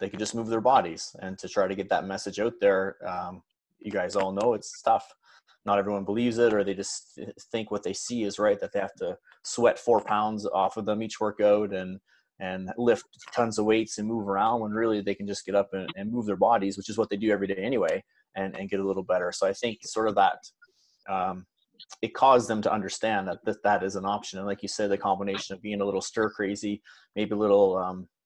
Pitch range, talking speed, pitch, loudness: 95-110 Hz, 250 wpm, 105 Hz, -27 LUFS